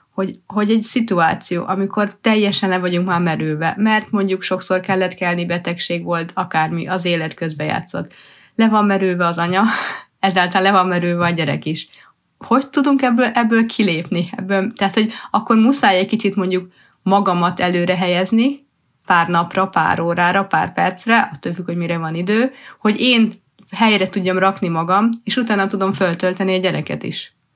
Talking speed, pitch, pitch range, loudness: 165 wpm, 190 Hz, 175-215 Hz, -17 LUFS